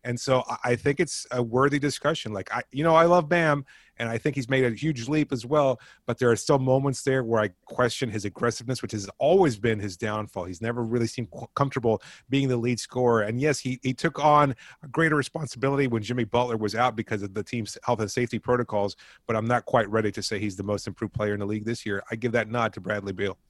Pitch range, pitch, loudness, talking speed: 110-135 Hz, 120 Hz, -26 LUFS, 250 wpm